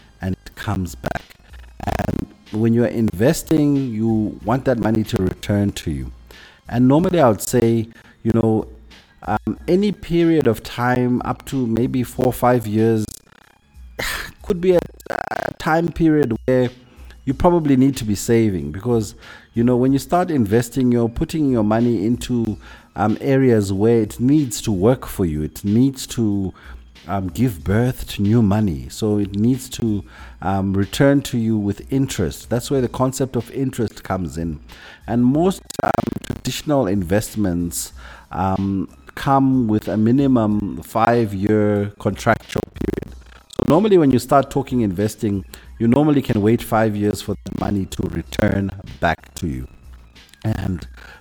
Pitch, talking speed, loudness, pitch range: 110 Hz, 150 wpm, -19 LUFS, 95-125 Hz